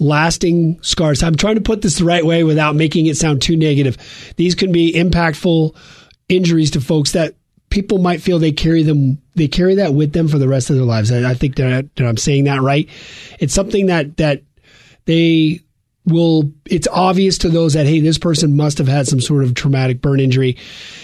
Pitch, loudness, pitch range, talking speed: 155 Hz, -14 LUFS, 140-170 Hz, 205 wpm